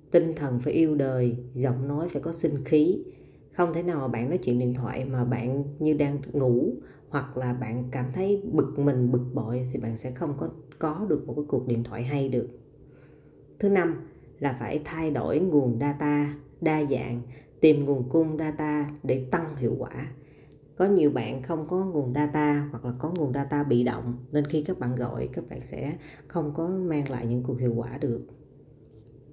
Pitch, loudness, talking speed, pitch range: 145 Hz, -27 LUFS, 195 wpm, 125-150 Hz